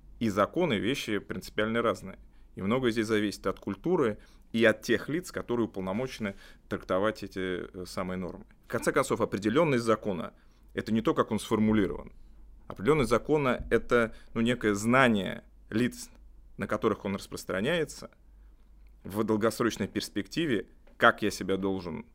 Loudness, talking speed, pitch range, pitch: -29 LUFS, 135 wpm, 95-115 Hz, 105 Hz